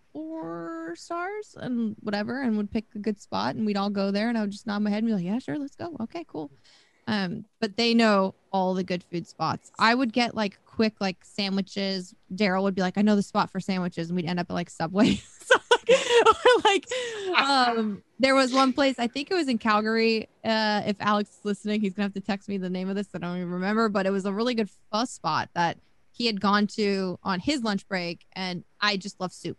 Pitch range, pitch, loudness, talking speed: 190-230 Hz, 210 Hz, -26 LUFS, 245 wpm